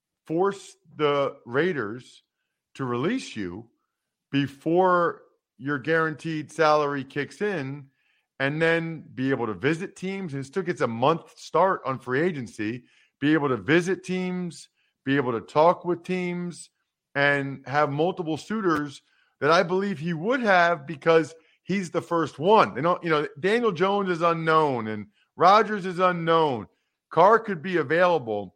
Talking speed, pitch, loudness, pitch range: 145 wpm, 165 Hz, -24 LUFS, 145-185 Hz